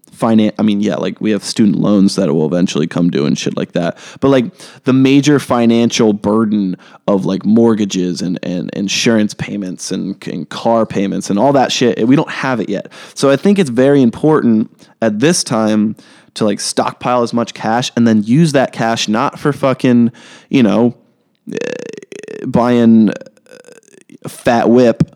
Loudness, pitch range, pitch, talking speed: -13 LUFS, 105-135 Hz, 115 Hz, 170 wpm